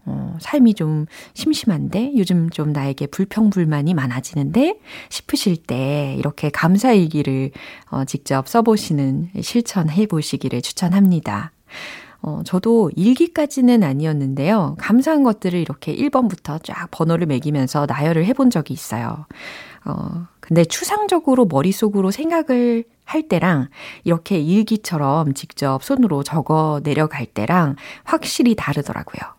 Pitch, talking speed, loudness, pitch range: 170 Hz, 300 characters per minute, -18 LUFS, 145-225 Hz